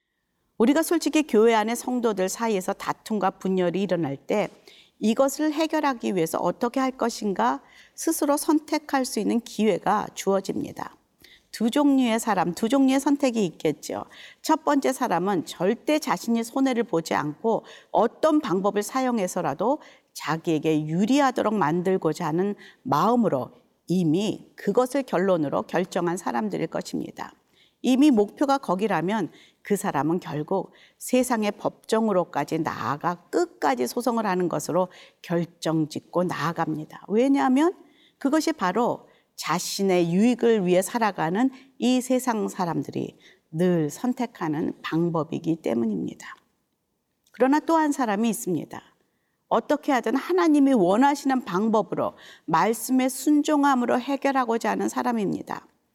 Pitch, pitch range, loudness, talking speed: 225 Hz, 180-270 Hz, -24 LUFS, 305 characters per minute